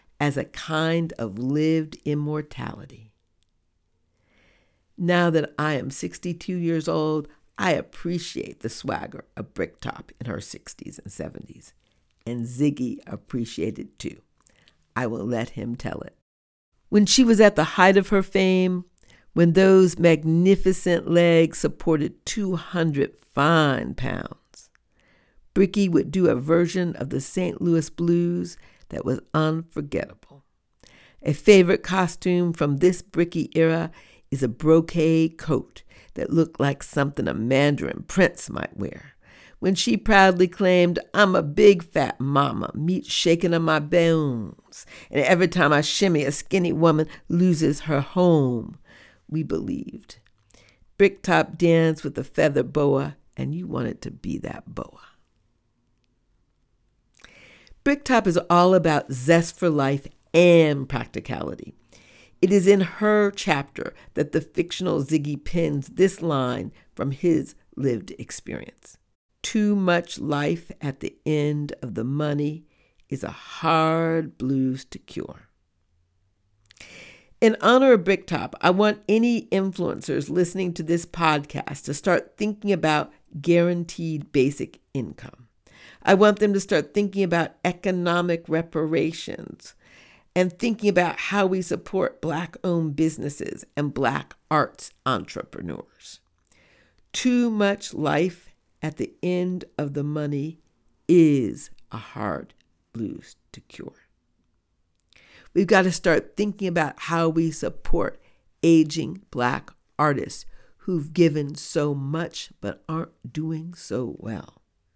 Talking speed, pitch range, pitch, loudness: 125 wpm, 140-180 Hz, 160 Hz, -22 LUFS